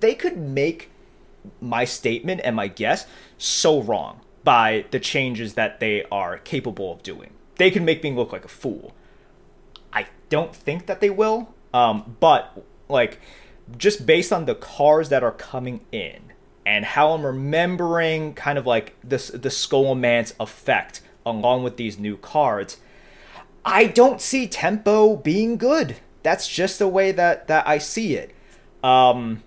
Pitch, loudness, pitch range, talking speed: 155 Hz, -21 LUFS, 125-200 Hz, 155 wpm